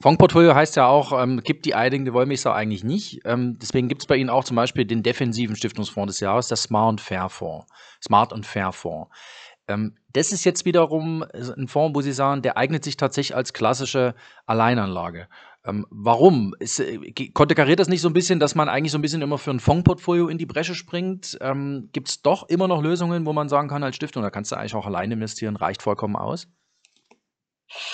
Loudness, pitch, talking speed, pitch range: -21 LUFS, 135 Hz, 215 wpm, 115-155 Hz